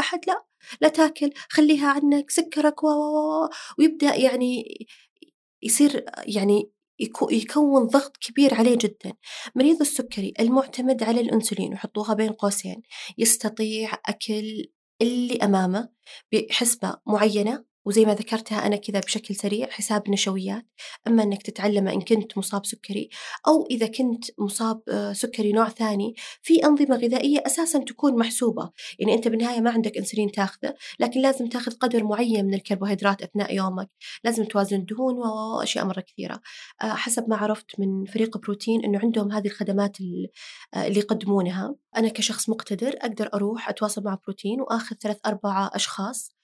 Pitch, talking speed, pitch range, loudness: 225 Hz, 135 wpm, 205-260 Hz, -24 LUFS